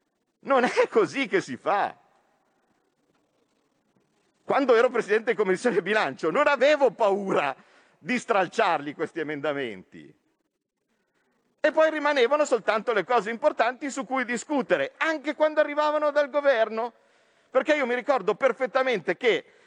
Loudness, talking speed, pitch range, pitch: -24 LUFS, 125 wpm, 240-305 Hz, 275 Hz